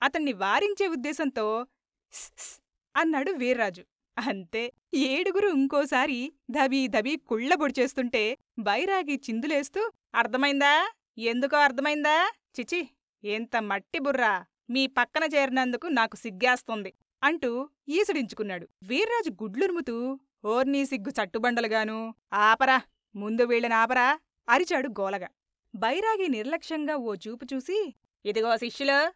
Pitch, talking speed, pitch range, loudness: 265 Hz, 90 wpm, 230-300 Hz, -27 LUFS